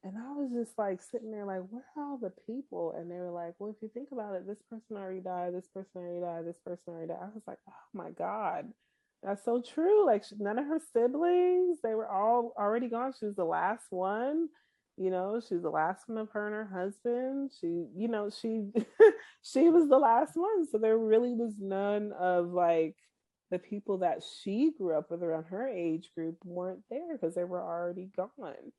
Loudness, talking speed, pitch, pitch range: -32 LUFS, 220 wpm, 210 Hz, 180-245 Hz